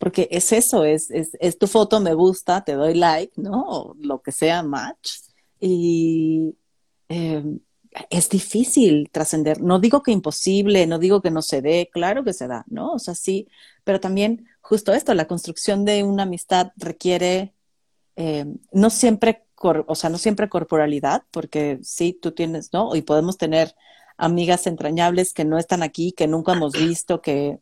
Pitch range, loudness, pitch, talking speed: 160-195 Hz, -20 LUFS, 175 Hz, 175 wpm